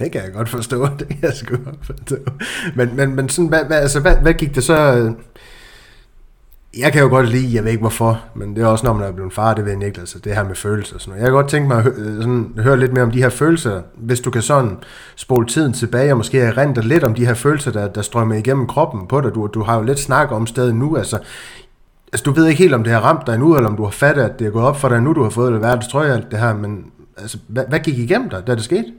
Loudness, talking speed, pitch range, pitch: -16 LUFS, 305 wpm, 110-140 Hz, 125 Hz